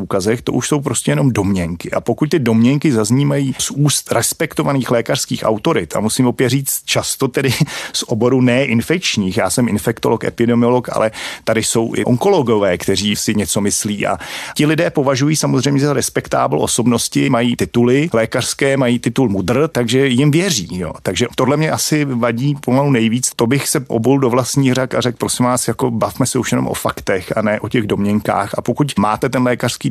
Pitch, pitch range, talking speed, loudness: 125 Hz, 115-140 Hz, 185 wpm, -15 LUFS